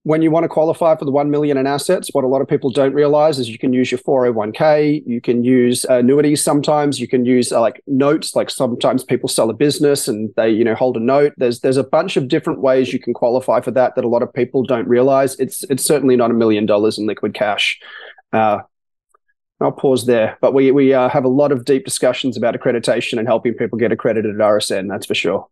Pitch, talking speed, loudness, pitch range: 130 Hz, 240 wpm, -16 LUFS, 120-145 Hz